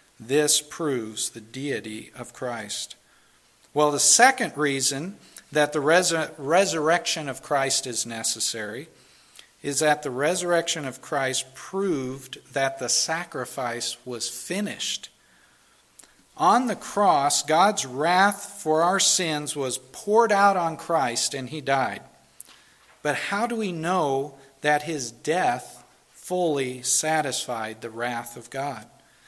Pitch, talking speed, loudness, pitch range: 145 Hz, 125 wpm, -24 LUFS, 130-170 Hz